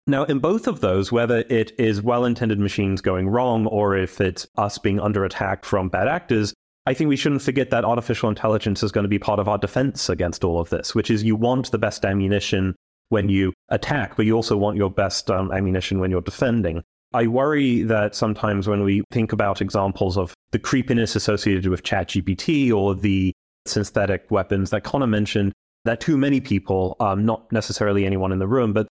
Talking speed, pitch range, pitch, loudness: 205 wpm, 95-115 Hz, 105 Hz, -21 LUFS